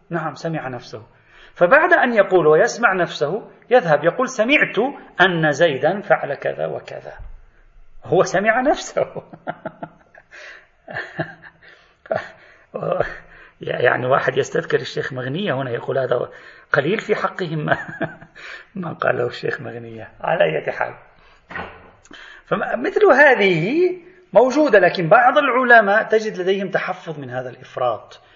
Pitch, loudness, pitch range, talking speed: 190 Hz, -18 LUFS, 155-255 Hz, 105 wpm